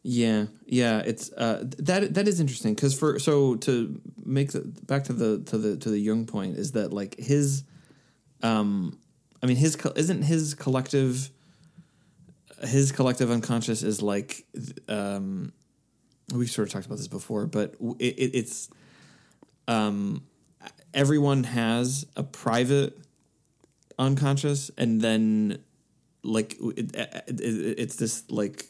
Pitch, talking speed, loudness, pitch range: 125 Hz, 140 wpm, -27 LUFS, 110-145 Hz